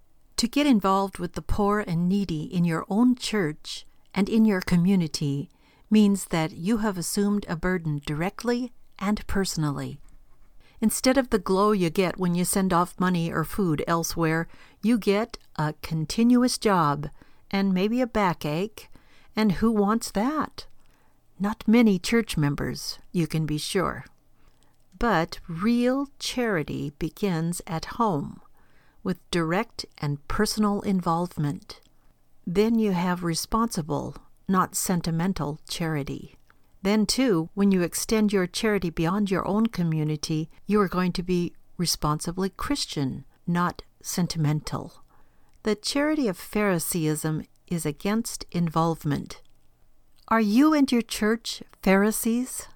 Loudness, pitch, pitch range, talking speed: -25 LUFS, 185 Hz, 165-215 Hz, 125 wpm